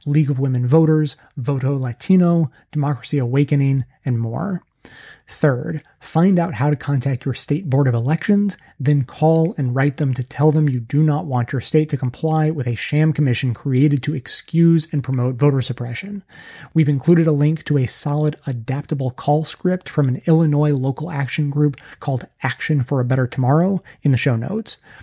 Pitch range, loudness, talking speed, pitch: 130-155 Hz, -19 LUFS, 175 wpm, 145 Hz